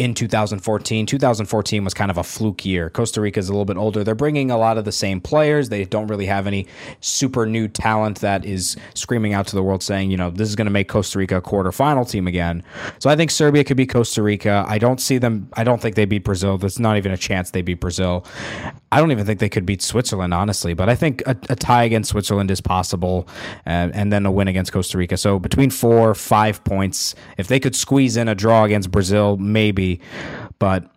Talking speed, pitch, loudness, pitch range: 240 wpm, 105 Hz, -19 LUFS, 95-115 Hz